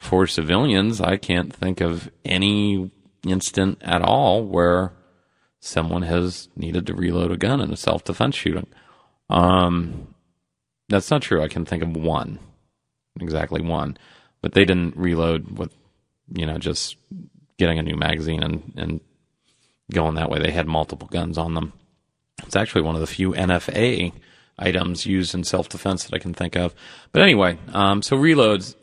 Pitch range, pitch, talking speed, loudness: 80-95 Hz, 90 Hz, 160 wpm, -21 LUFS